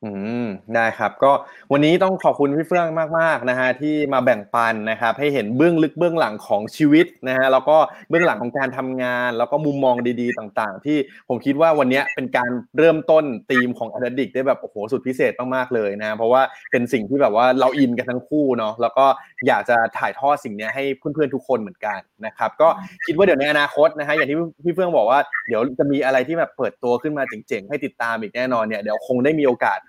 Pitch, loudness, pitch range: 135 Hz, -19 LUFS, 125-155 Hz